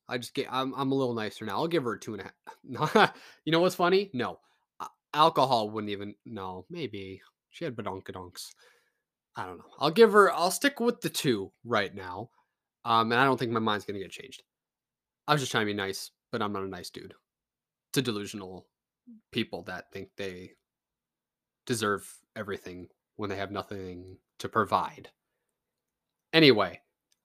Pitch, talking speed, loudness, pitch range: 110 Hz, 180 wpm, -28 LUFS, 95-135 Hz